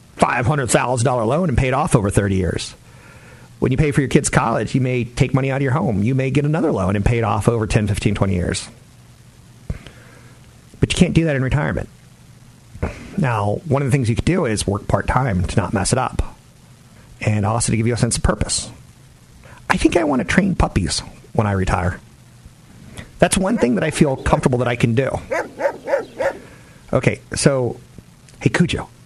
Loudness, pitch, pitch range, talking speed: -19 LUFS, 125 Hz, 110-145 Hz, 195 wpm